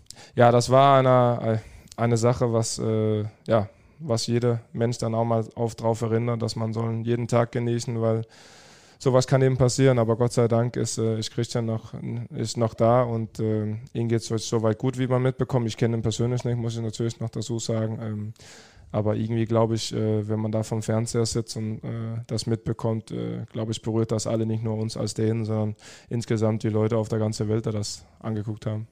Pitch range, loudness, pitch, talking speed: 110-120 Hz, -25 LUFS, 115 Hz, 210 wpm